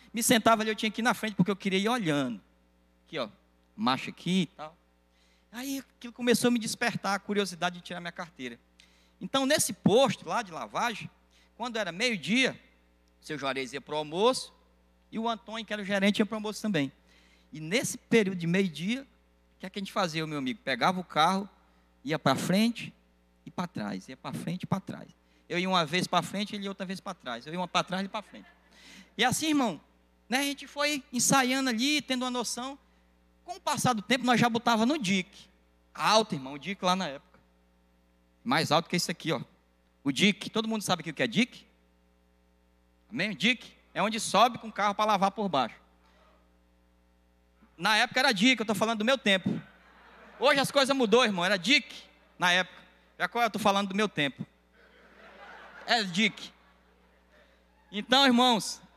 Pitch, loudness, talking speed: 190 Hz, -28 LUFS, 195 wpm